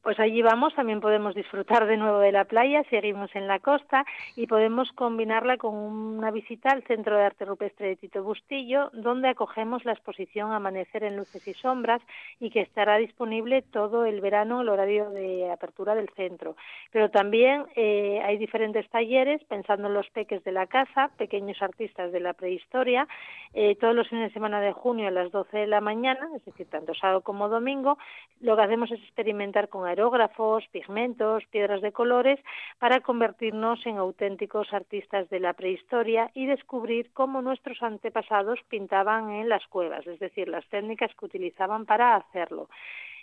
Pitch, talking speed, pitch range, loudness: 220 Hz, 175 wpm, 200-240 Hz, -27 LUFS